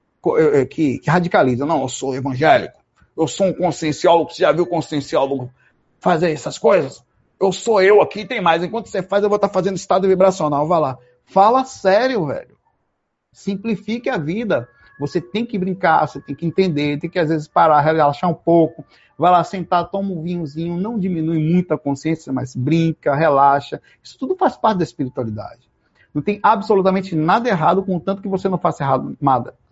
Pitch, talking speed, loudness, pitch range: 170 Hz, 180 wpm, -18 LUFS, 150-195 Hz